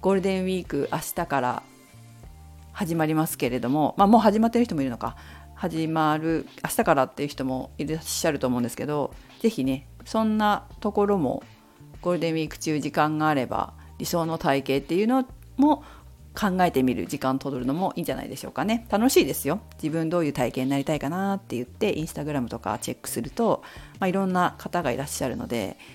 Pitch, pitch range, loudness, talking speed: 155 Hz, 130-190 Hz, -25 LUFS, 425 characters per minute